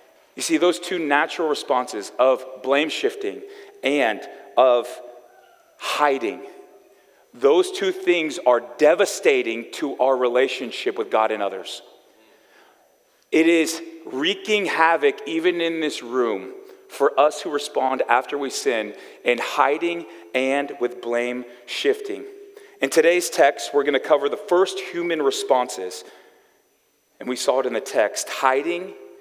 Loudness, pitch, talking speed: -21 LUFS, 180 Hz, 130 wpm